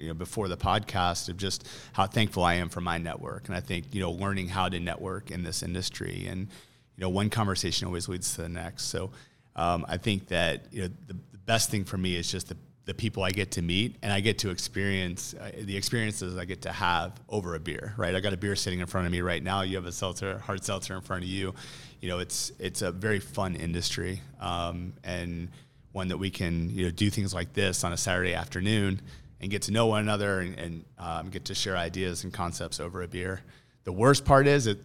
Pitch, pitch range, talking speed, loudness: 95 Hz, 90-100 Hz, 245 wpm, -30 LUFS